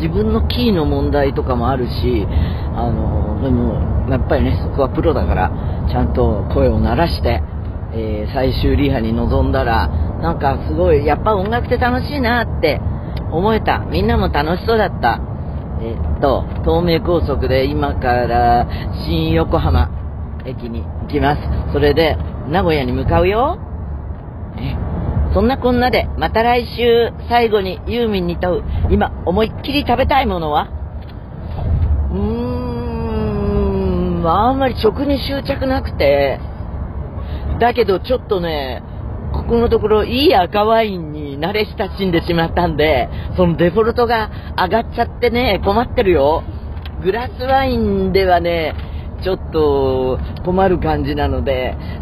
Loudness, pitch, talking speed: -17 LUFS, 110 Hz, 275 characters per minute